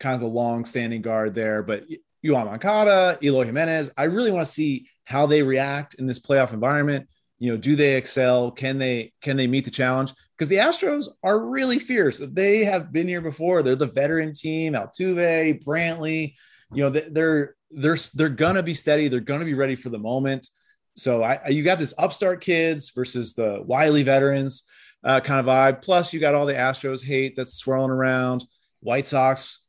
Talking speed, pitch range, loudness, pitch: 190 wpm, 130-160 Hz, -22 LUFS, 140 Hz